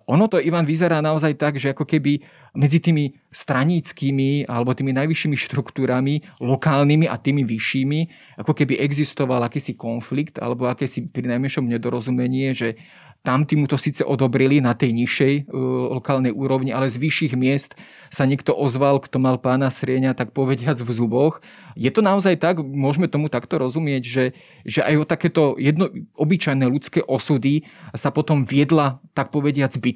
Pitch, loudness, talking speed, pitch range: 140 Hz, -20 LUFS, 160 wpm, 130-155 Hz